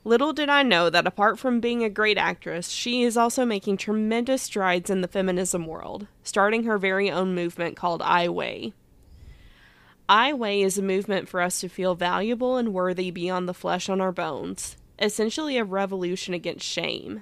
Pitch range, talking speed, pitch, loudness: 180-225 Hz, 180 wpm, 195 Hz, -24 LUFS